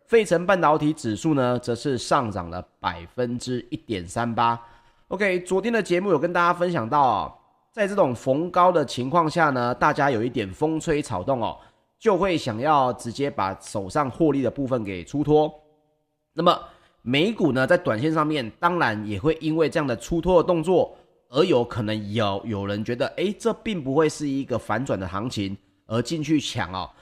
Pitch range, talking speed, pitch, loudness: 115-165 Hz, 275 characters per minute, 140 Hz, -23 LUFS